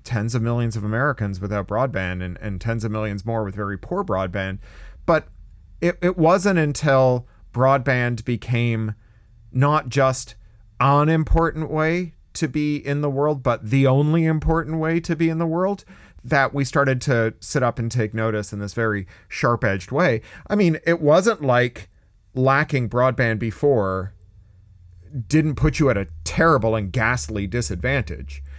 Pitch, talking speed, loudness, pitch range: 120 Hz, 160 wpm, -21 LUFS, 105-150 Hz